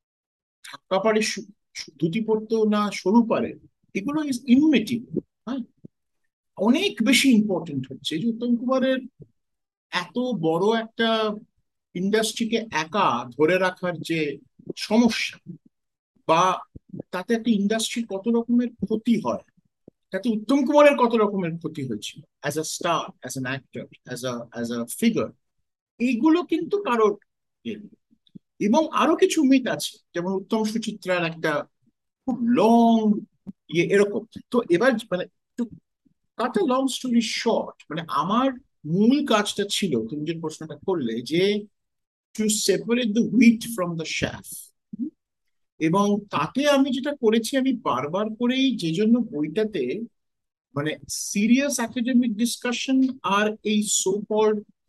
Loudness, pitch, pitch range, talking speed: -23 LUFS, 220 Hz, 180-245 Hz, 120 wpm